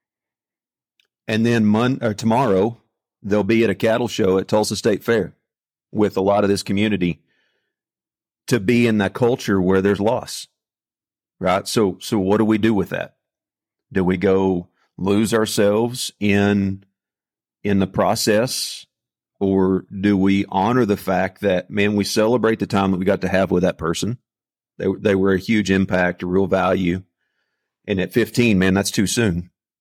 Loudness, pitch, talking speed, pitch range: -19 LUFS, 100 Hz, 165 wpm, 95-110 Hz